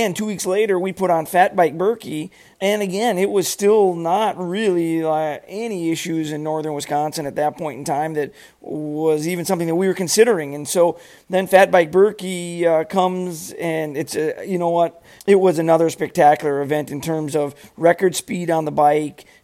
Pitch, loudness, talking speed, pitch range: 170 Hz, -19 LUFS, 195 wpm, 155-190 Hz